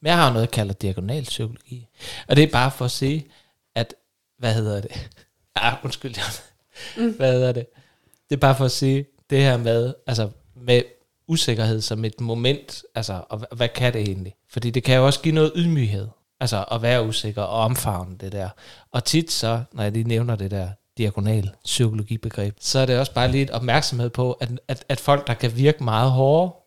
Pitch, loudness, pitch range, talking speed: 120 Hz, -22 LUFS, 110-135 Hz, 210 wpm